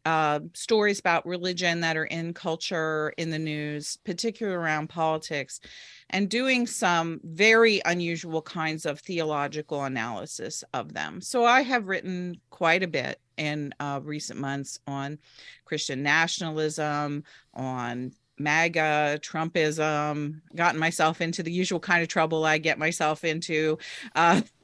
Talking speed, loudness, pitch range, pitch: 130 wpm, -26 LUFS, 150-175 Hz, 160 Hz